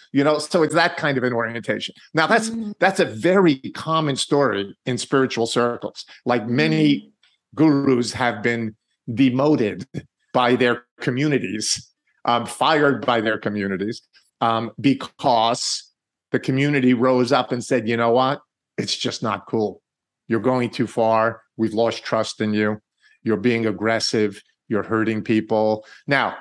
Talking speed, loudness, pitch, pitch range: 145 wpm, -21 LUFS, 120 Hz, 110-135 Hz